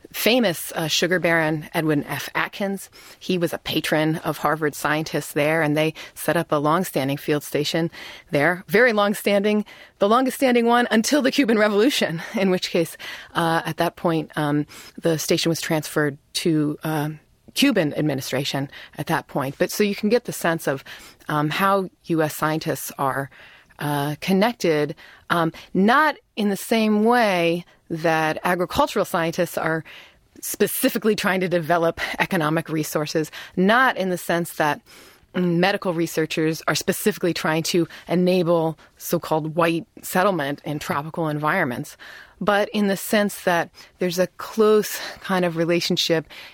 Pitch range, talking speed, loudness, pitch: 155-195 Hz, 145 wpm, -22 LUFS, 170 Hz